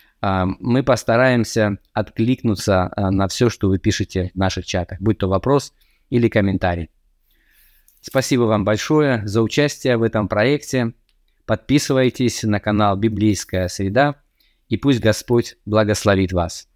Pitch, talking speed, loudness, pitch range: 110 Hz, 120 wpm, -19 LUFS, 95-125 Hz